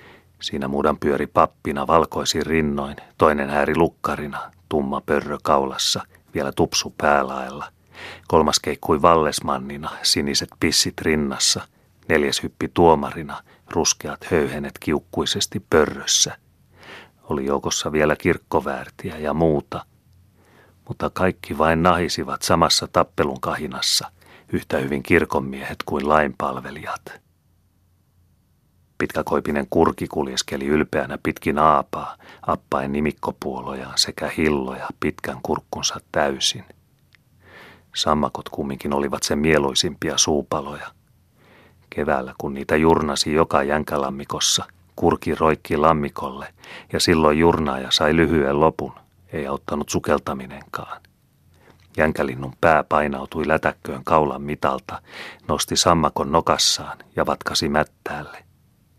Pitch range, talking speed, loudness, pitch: 70-80 Hz, 95 wpm, -21 LUFS, 75 Hz